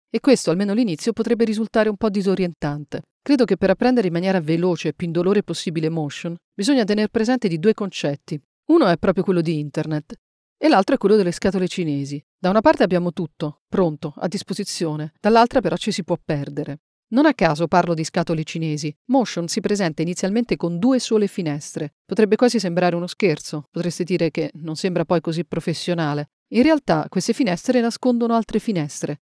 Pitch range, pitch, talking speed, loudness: 165-220 Hz, 180 Hz, 180 wpm, -20 LUFS